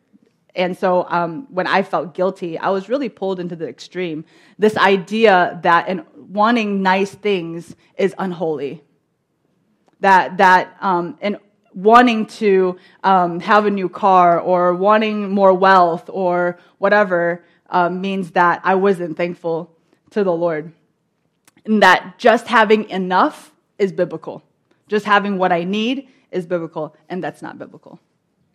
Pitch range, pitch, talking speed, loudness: 175-205 Hz, 185 Hz, 135 wpm, -17 LUFS